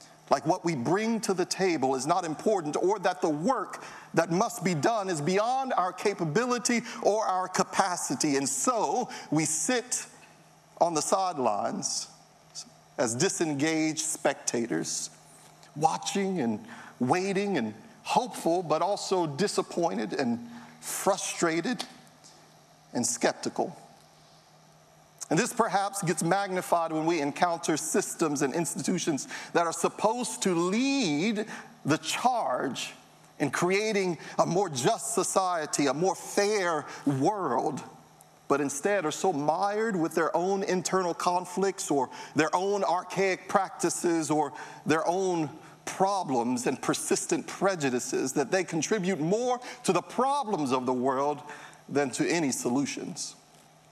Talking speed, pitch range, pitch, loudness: 125 wpm, 160-205 Hz, 185 Hz, -28 LUFS